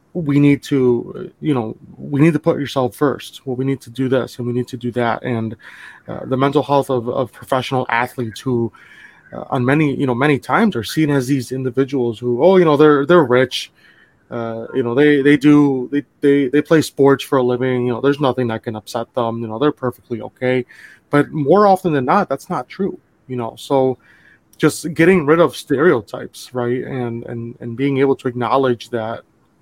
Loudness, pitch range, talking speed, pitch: -17 LUFS, 120-145 Hz, 210 wpm, 130 Hz